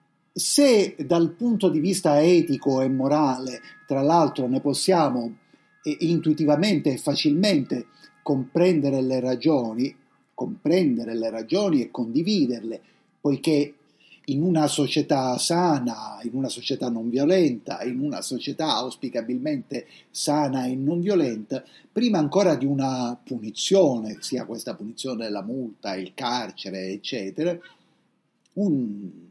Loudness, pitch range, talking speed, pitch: -24 LUFS, 125-165 Hz, 115 wpm, 140 Hz